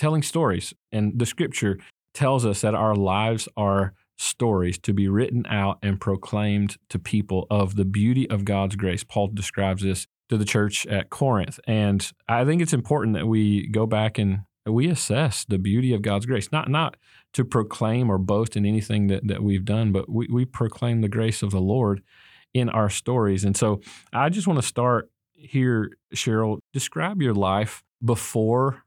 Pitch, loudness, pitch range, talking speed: 110 Hz, -24 LUFS, 100-120 Hz, 185 wpm